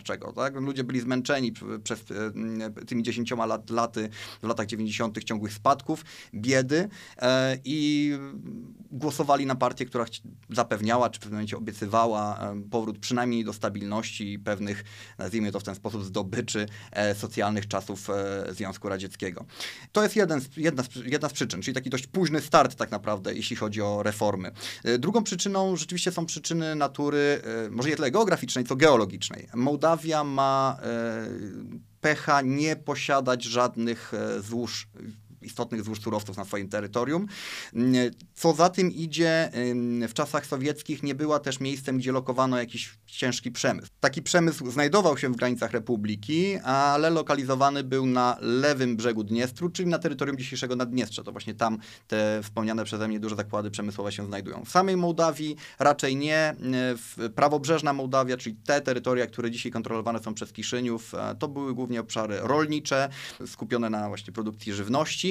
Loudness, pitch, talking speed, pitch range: -27 LUFS, 125 Hz, 150 wpm, 110-145 Hz